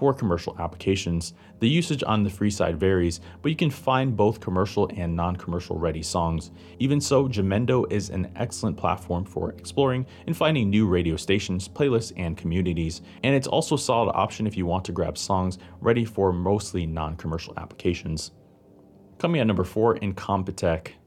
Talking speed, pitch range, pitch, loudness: 175 wpm, 90-115 Hz, 95 Hz, -25 LUFS